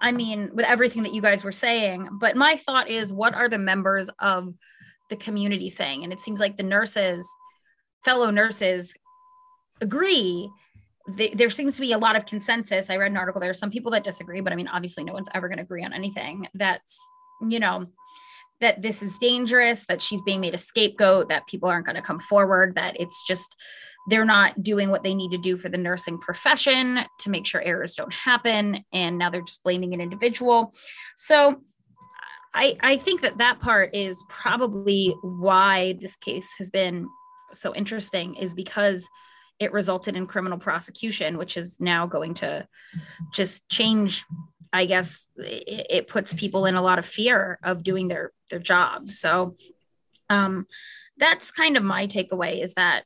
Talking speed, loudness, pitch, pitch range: 185 wpm, -23 LUFS, 200 Hz, 185-235 Hz